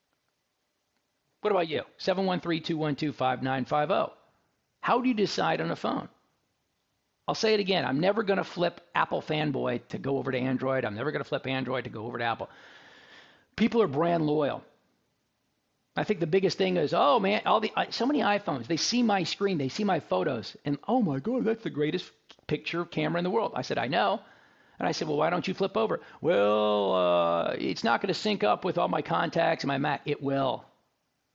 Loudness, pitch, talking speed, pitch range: -28 LUFS, 165 Hz, 205 wpm, 130-195 Hz